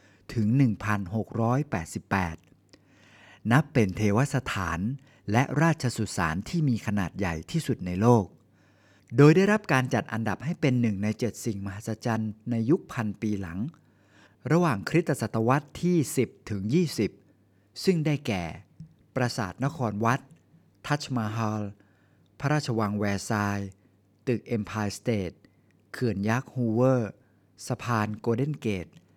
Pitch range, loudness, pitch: 100-130 Hz, -27 LUFS, 110 Hz